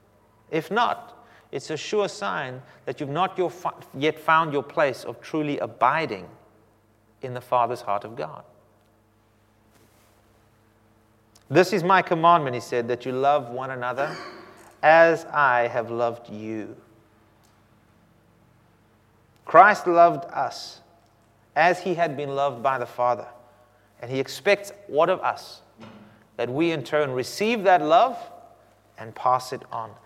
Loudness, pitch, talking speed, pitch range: -23 LUFS, 120 Hz, 135 wpm, 110-150 Hz